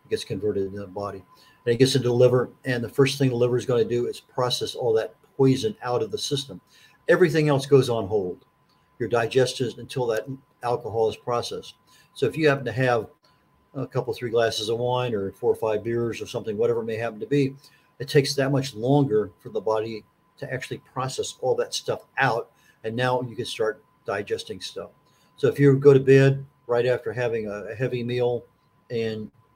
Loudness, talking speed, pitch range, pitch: -24 LUFS, 205 wpm, 115-145 Hz, 125 Hz